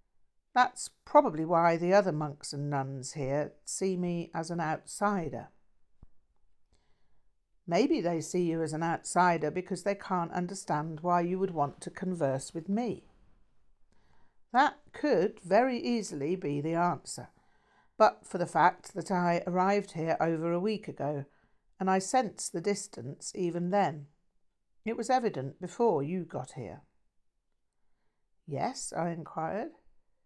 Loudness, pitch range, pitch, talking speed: -31 LUFS, 145-190 Hz, 170 Hz, 135 wpm